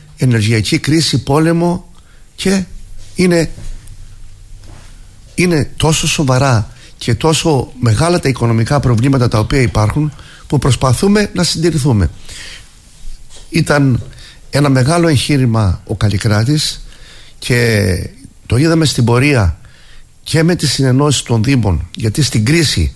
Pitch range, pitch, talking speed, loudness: 105-150 Hz, 130 Hz, 105 wpm, -13 LUFS